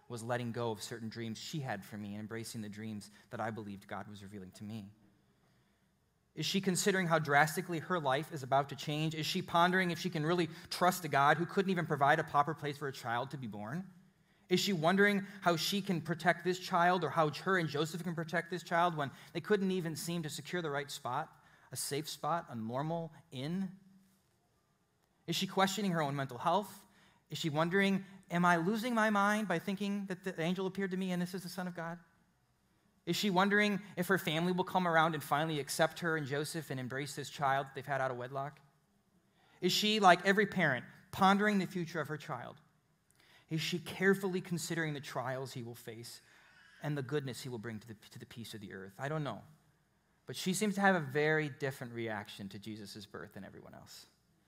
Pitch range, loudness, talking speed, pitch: 135-185 Hz, -34 LUFS, 215 wpm, 160 Hz